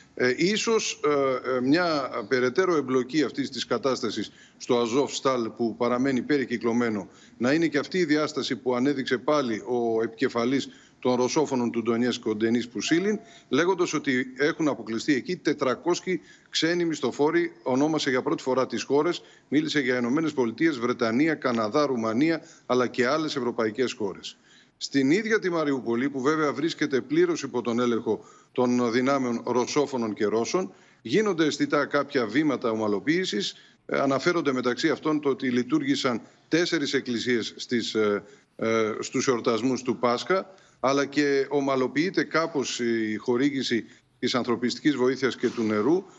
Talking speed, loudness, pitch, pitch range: 135 wpm, -26 LUFS, 130 Hz, 120-150 Hz